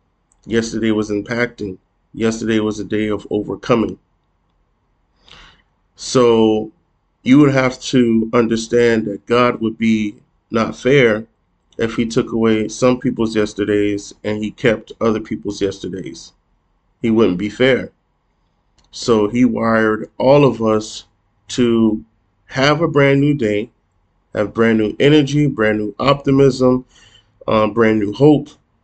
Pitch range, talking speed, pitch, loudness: 105-120 Hz, 125 wpm, 110 Hz, -16 LUFS